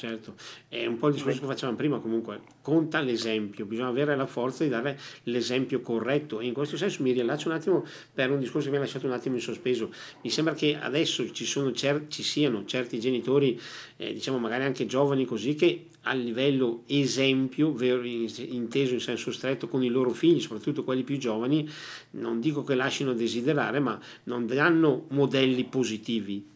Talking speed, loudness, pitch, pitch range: 185 wpm, -28 LUFS, 130 Hz, 120-145 Hz